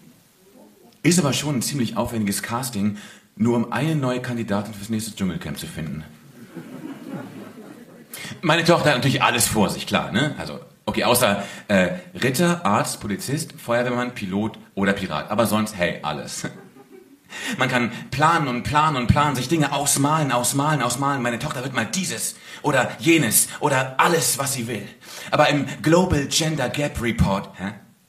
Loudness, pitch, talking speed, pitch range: -21 LUFS, 130 Hz, 155 wpm, 115-150 Hz